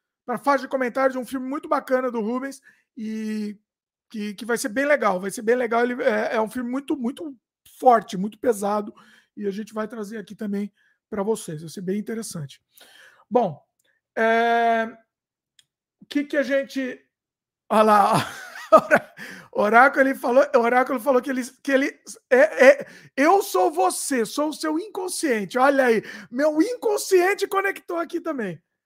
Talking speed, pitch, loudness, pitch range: 165 wpm, 250 Hz, -22 LUFS, 220-290 Hz